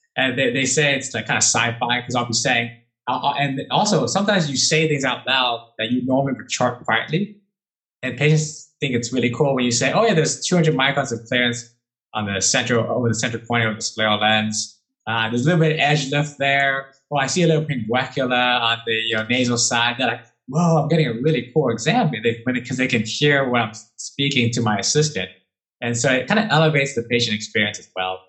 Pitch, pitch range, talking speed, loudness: 125 Hz, 115-145 Hz, 230 wpm, -19 LUFS